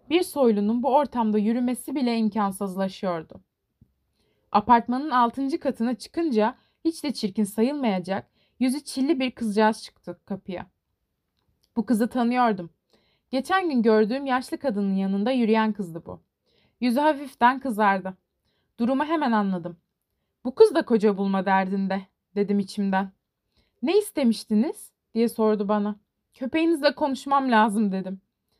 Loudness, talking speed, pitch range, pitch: -24 LUFS, 115 wpm, 200-265 Hz, 230 Hz